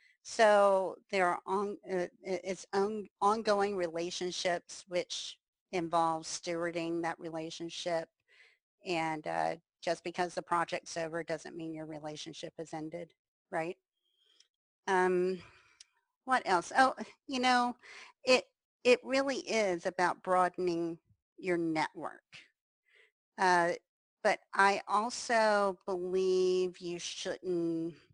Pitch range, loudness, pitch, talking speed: 170-205 Hz, -33 LUFS, 180 Hz, 105 wpm